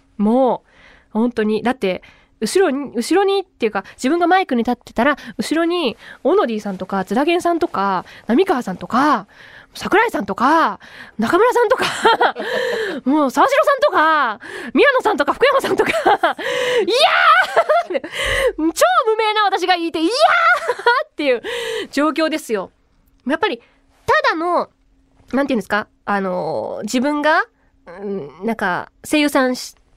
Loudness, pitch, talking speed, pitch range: -17 LUFS, 310 Hz, 285 characters per minute, 240-390 Hz